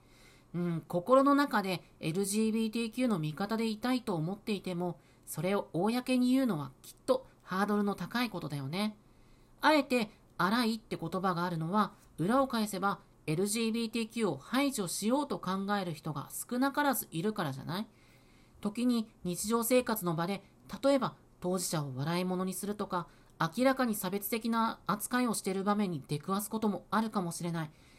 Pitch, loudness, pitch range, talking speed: 200 Hz, -33 LUFS, 175-230 Hz, 335 characters per minute